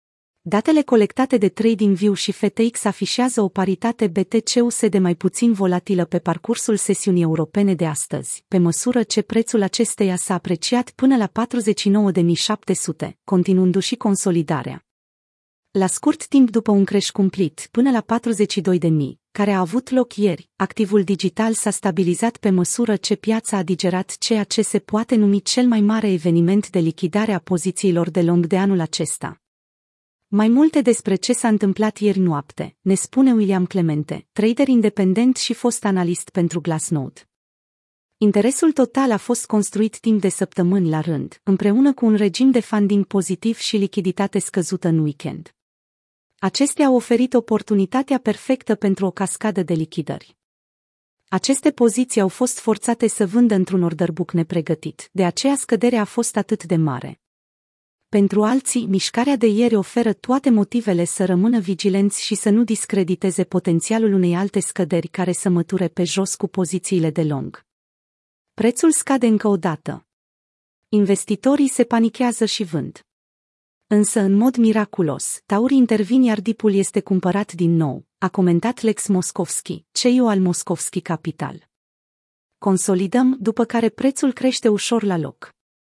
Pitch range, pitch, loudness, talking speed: 180-230 Hz, 200 Hz, -19 LUFS, 145 wpm